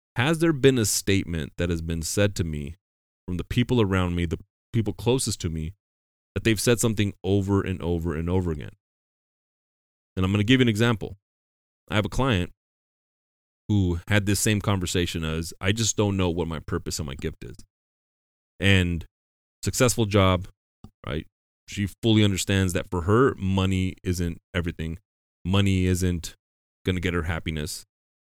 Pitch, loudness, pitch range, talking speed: 95 Hz, -25 LUFS, 80-105 Hz, 170 wpm